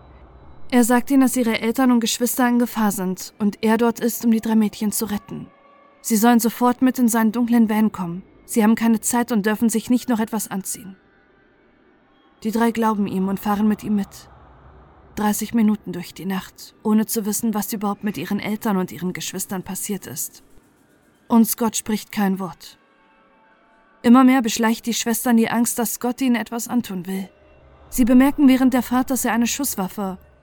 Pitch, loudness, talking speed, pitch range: 225 Hz, -20 LUFS, 185 wpm, 205-240 Hz